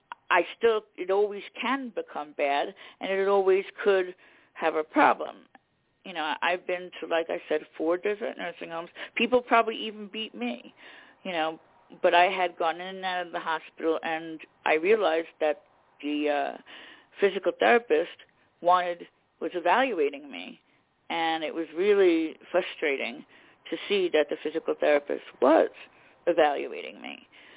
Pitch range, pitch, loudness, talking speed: 165-235 Hz, 180 Hz, -27 LUFS, 150 wpm